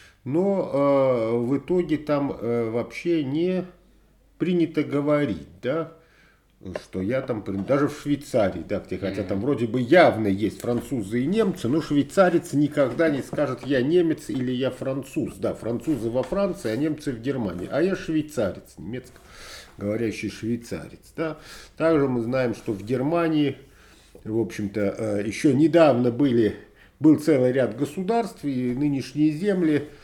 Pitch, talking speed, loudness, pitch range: 140 Hz, 145 wpm, -24 LUFS, 115-160 Hz